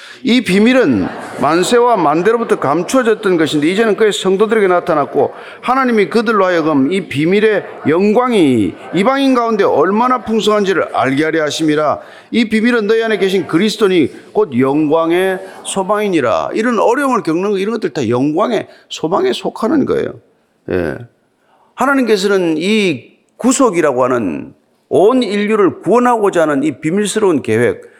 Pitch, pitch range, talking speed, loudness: 215 Hz, 185-240 Hz, 335 characters per minute, -13 LUFS